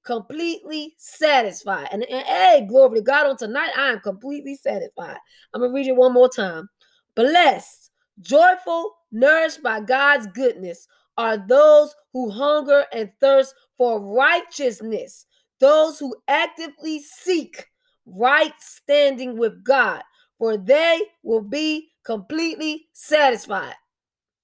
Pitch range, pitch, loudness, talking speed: 240-310 Hz, 280 Hz, -19 LUFS, 125 wpm